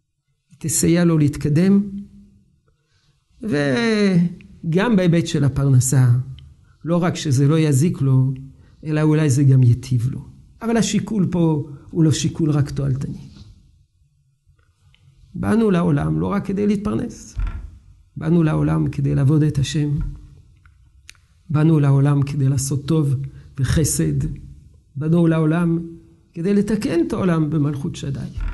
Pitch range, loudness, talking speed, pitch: 130-165 Hz, -19 LUFS, 110 wpm, 145 Hz